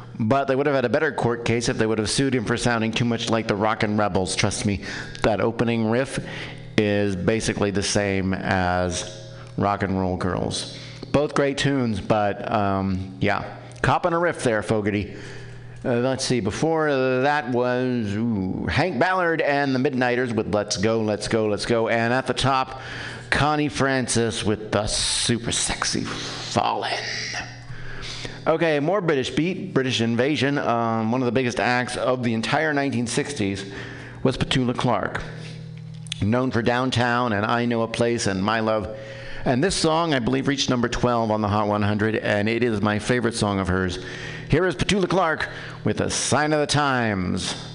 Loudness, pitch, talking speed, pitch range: -23 LUFS, 120 Hz, 175 wpm, 105-135 Hz